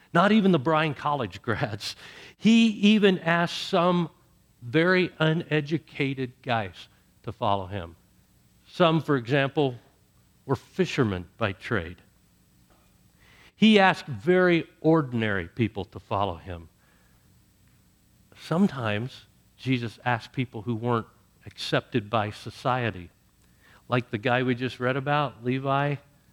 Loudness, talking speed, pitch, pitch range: -25 LUFS, 110 wpm, 125 Hz, 105-155 Hz